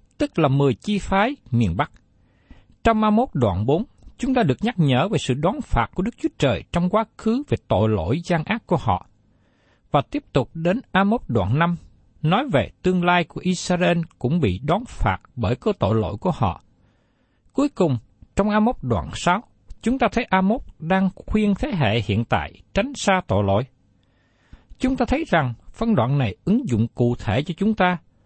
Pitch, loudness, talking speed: 170 Hz, -22 LUFS, 200 wpm